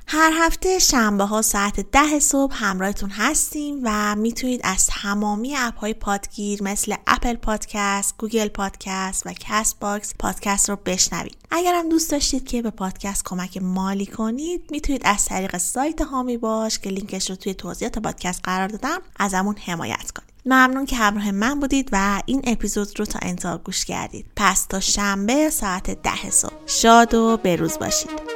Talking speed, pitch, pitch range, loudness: 165 wpm, 215 Hz, 200-260 Hz, -21 LUFS